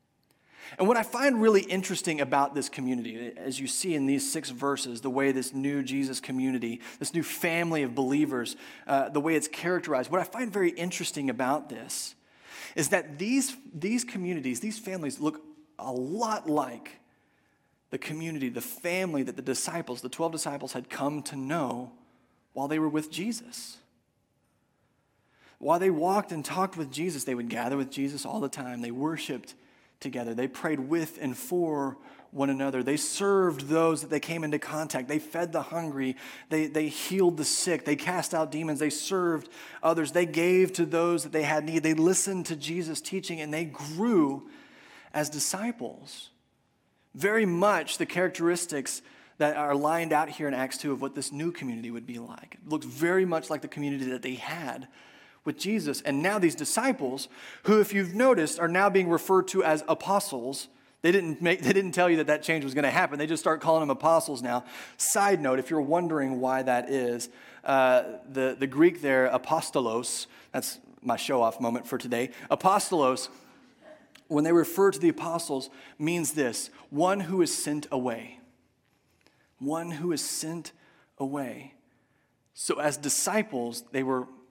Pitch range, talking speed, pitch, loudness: 135-180 Hz, 175 wpm, 155 Hz, -28 LUFS